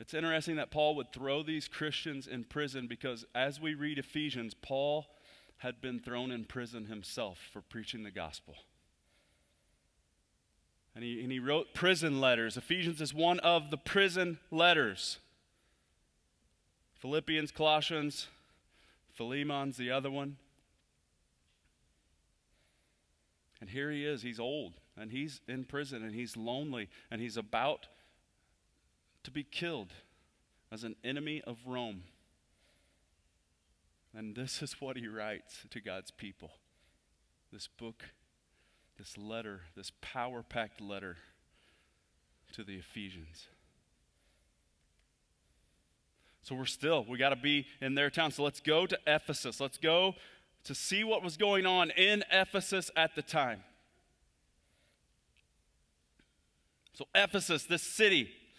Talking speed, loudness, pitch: 125 wpm, -34 LUFS, 120 Hz